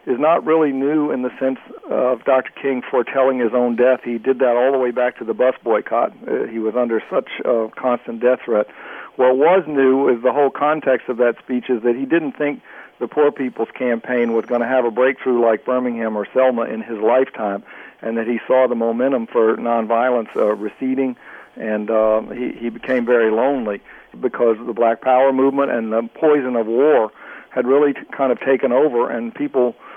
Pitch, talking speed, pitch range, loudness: 125 Hz, 210 wpm, 115-130 Hz, -18 LUFS